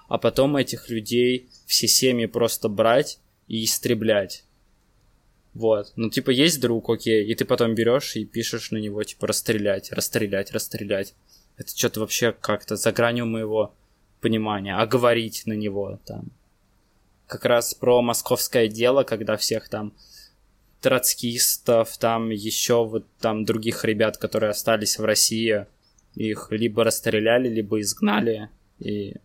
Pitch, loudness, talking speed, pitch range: 110 Hz, -22 LUFS, 135 wpm, 105-115 Hz